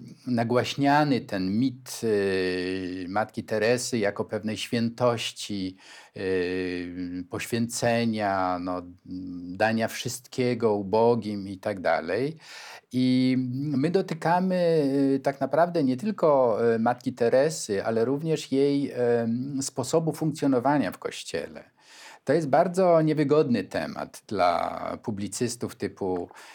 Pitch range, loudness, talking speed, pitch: 100-140 Hz, -26 LUFS, 90 wpm, 120 Hz